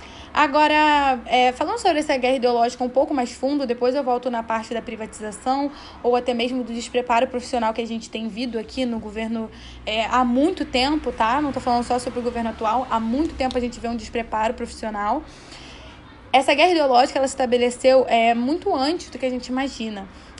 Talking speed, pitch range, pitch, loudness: 200 wpm, 230-270 Hz, 245 Hz, -21 LUFS